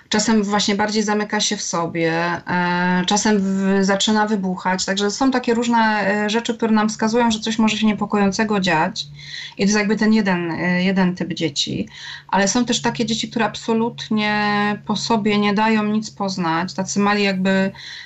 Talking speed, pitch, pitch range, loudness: 175 wpm, 210 Hz, 190-220 Hz, -19 LUFS